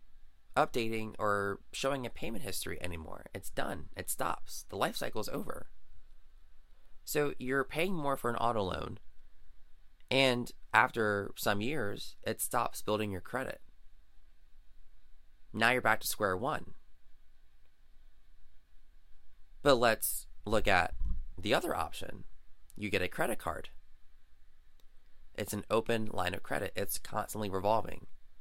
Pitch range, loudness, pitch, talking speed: 65-110 Hz, -34 LUFS, 85 Hz, 125 wpm